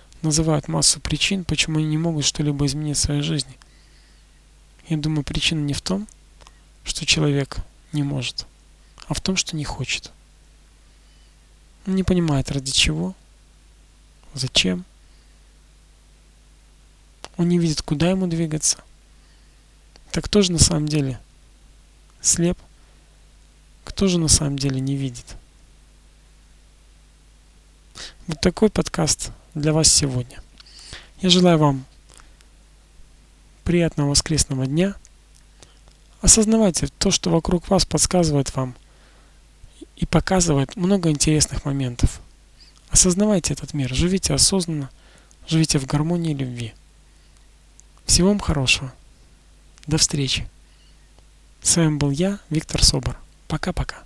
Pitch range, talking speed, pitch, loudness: 120-165 Hz, 110 wpm, 145 Hz, -20 LUFS